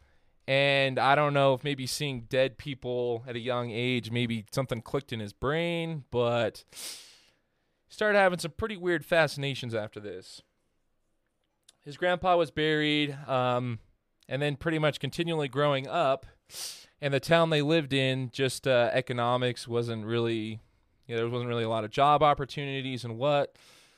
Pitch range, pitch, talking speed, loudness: 120-145 Hz, 135 Hz, 160 wpm, -28 LUFS